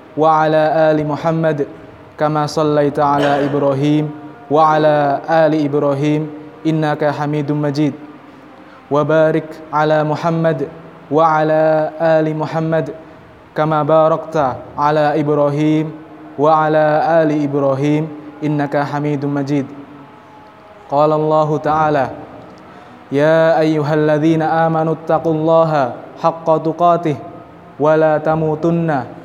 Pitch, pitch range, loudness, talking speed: 155 Hz, 150-160 Hz, -15 LUFS, 85 wpm